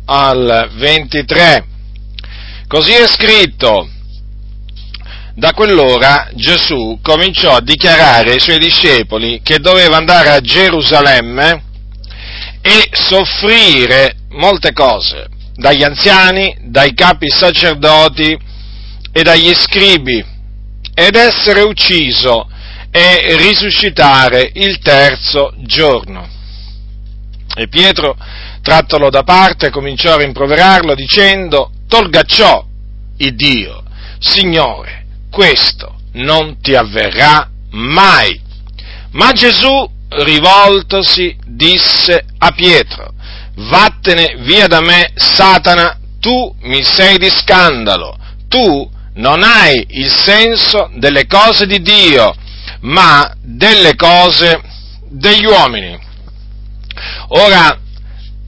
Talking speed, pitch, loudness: 90 wpm, 145 Hz, -7 LUFS